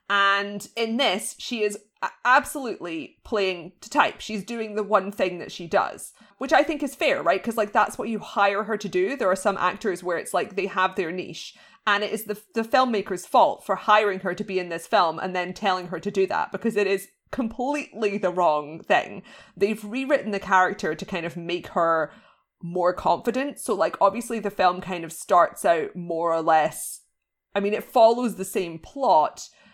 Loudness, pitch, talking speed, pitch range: -24 LUFS, 200 Hz, 205 wpm, 180-225 Hz